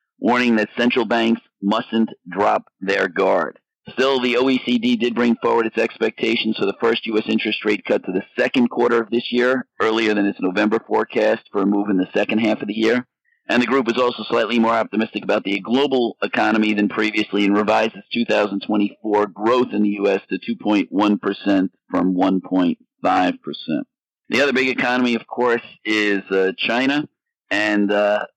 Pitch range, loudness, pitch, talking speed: 105-125 Hz, -19 LUFS, 110 Hz, 175 wpm